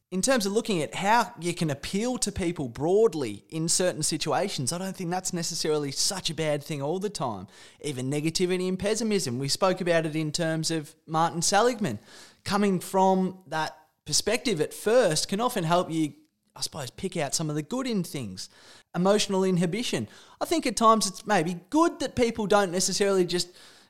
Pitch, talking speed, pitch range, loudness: 185 Hz, 185 wpm, 160-205 Hz, -26 LUFS